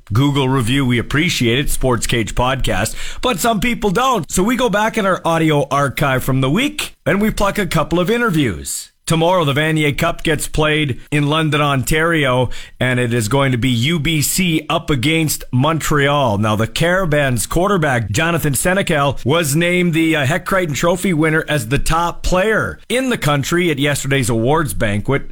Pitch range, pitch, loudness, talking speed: 130-170 Hz, 150 Hz, -16 LUFS, 175 wpm